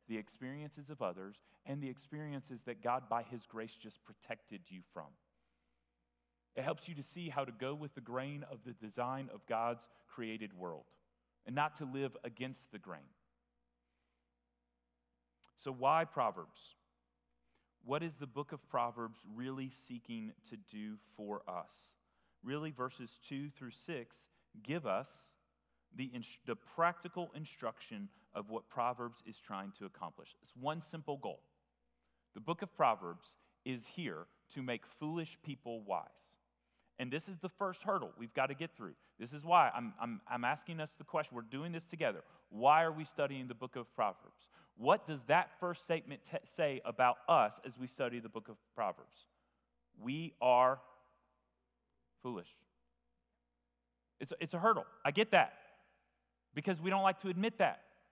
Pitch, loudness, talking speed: 125 Hz, -39 LUFS, 160 wpm